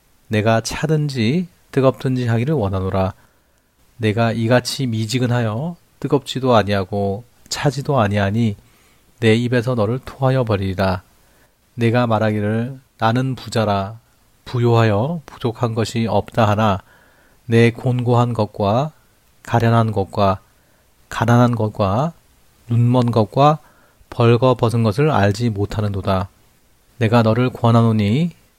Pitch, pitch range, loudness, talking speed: 115 Hz, 105-125 Hz, -18 LUFS, 250 characters per minute